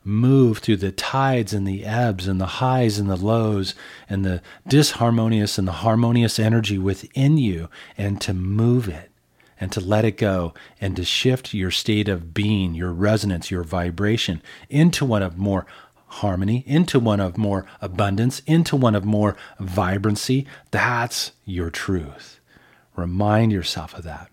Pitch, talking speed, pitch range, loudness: 105 Hz, 160 wpm, 95-115 Hz, -21 LUFS